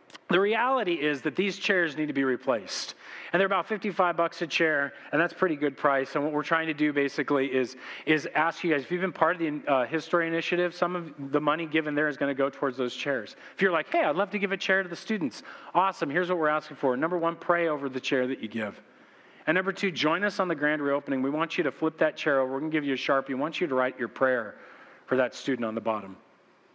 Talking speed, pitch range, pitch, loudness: 270 wpm, 140-175 Hz, 155 Hz, -27 LUFS